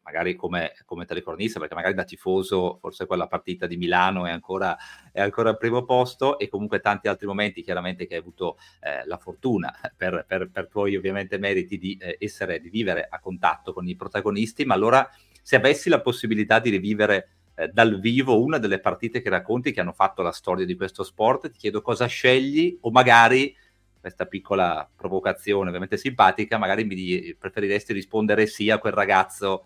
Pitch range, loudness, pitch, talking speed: 95-115 Hz, -23 LUFS, 105 Hz, 180 wpm